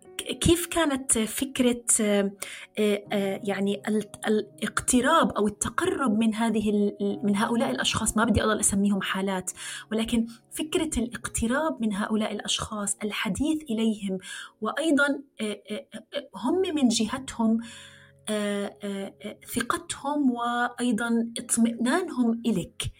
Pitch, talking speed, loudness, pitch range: 225 Hz, 85 wpm, -26 LUFS, 205-250 Hz